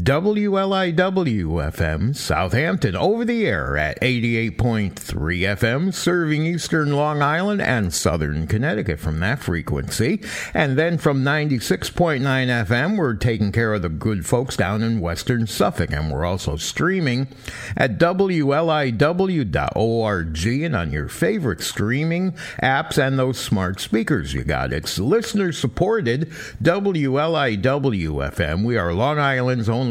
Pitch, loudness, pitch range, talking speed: 125 Hz, -21 LUFS, 100-155 Hz, 125 wpm